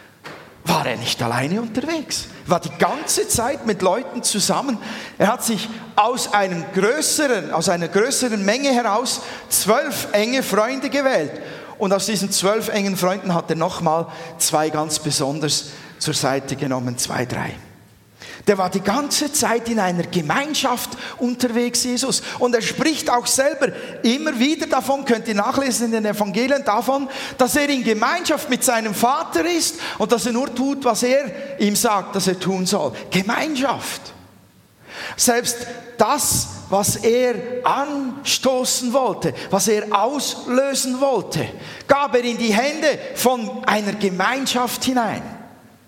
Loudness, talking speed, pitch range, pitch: -20 LUFS, 145 wpm, 195-265 Hz, 235 Hz